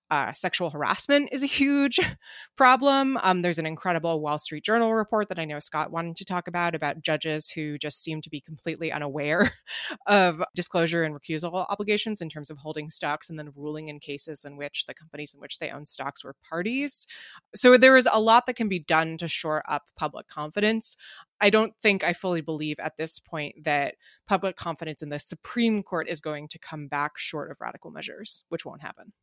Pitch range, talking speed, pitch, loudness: 150-210 Hz, 205 wpm, 165 Hz, -25 LUFS